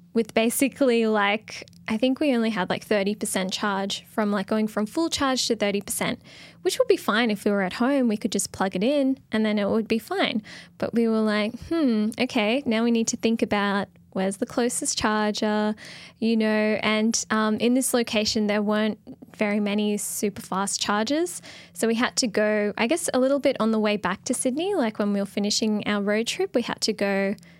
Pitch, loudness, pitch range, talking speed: 220 Hz, -24 LUFS, 210-245 Hz, 215 wpm